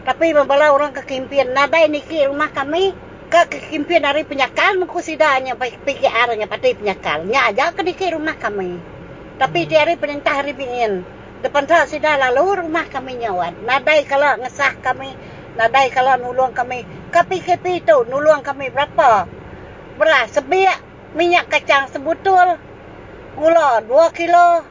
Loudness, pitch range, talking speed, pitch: -16 LUFS, 260-330 Hz, 140 wpm, 290 Hz